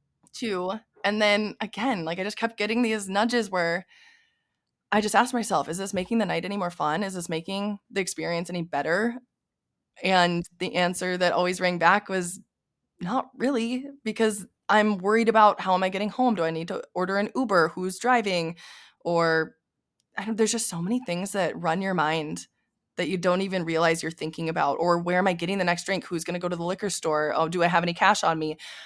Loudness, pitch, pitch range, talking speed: -25 LUFS, 185 Hz, 170-215 Hz, 215 wpm